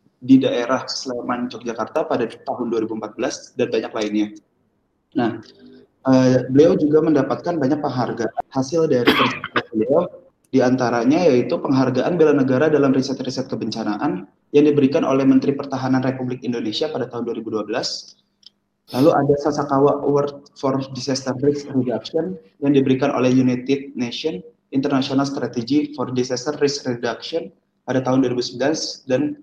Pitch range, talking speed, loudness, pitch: 125-145 Hz, 125 wpm, -20 LUFS, 130 Hz